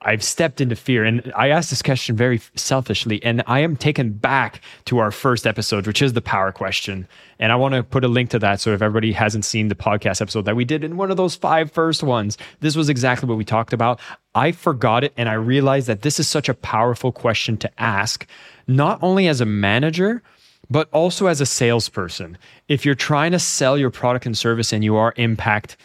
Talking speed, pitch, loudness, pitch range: 225 wpm, 125 Hz, -19 LUFS, 110-145 Hz